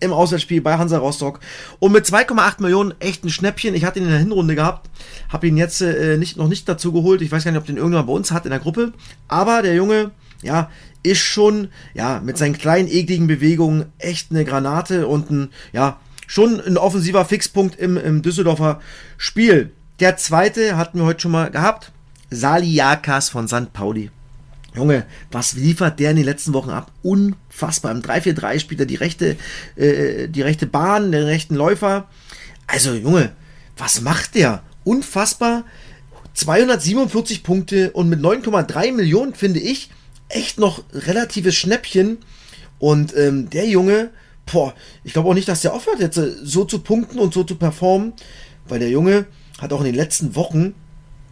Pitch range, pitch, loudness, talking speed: 145-190 Hz, 165 Hz, -17 LUFS, 175 wpm